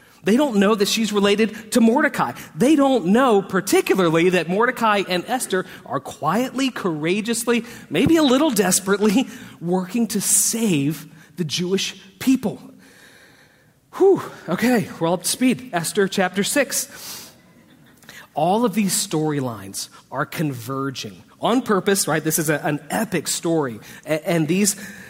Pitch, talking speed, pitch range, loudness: 200 Hz, 135 wpm, 170-235 Hz, -20 LUFS